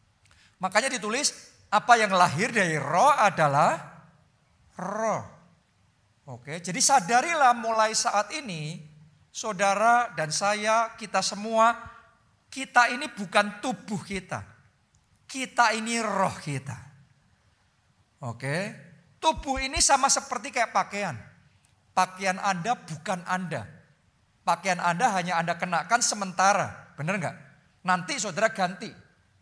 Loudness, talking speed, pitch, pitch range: -25 LUFS, 105 wpm, 190 Hz, 150-230 Hz